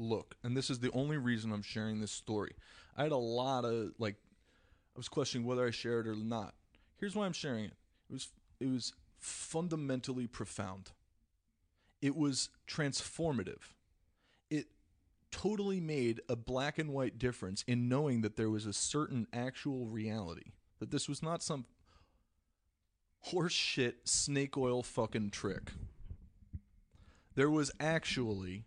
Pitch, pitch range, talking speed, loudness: 115 Hz, 95-135 Hz, 150 wpm, -38 LUFS